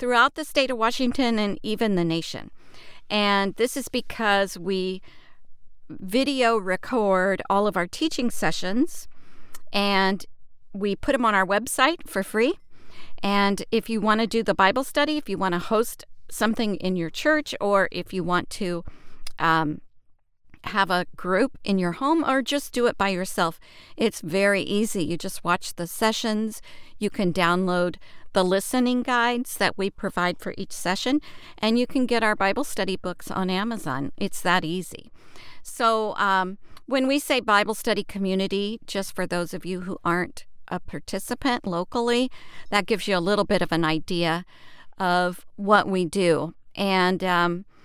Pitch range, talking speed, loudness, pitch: 185-230 Hz, 165 wpm, -24 LUFS, 200 Hz